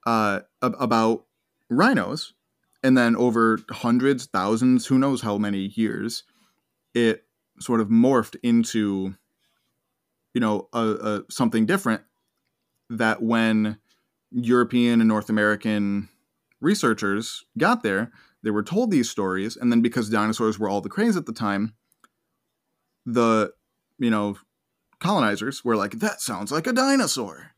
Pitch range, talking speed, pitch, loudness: 105-120 Hz, 130 wpm, 115 Hz, -23 LUFS